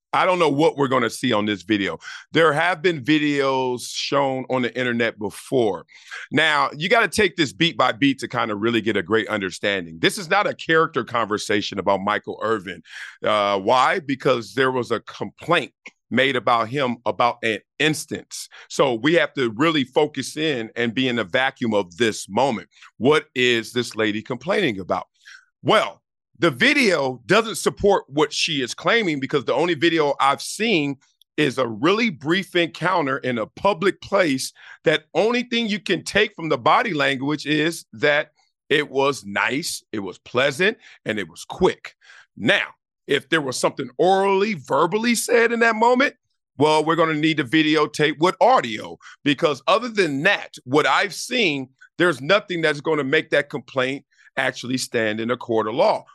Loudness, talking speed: -21 LUFS, 180 wpm